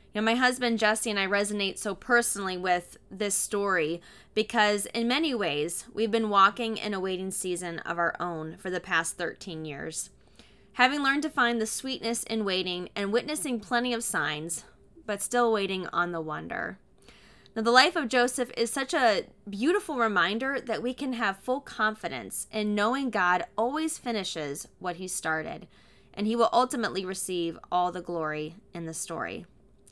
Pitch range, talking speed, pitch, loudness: 180-235 Hz, 170 wpm, 210 Hz, -28 LUFS